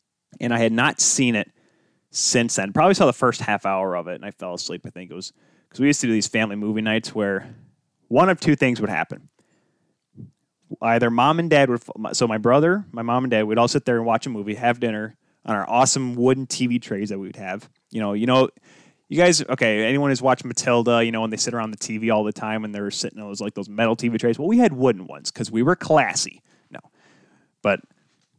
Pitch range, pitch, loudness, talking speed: 110-130 Hz, 115 Hz, -21 LUFS, 245 wpm